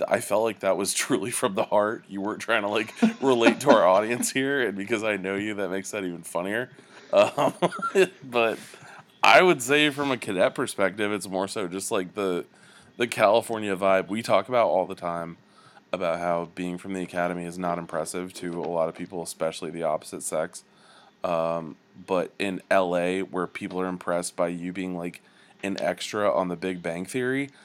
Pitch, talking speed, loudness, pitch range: 95 Hz, 195 wpm, -25 LUFS, 85-110 Hz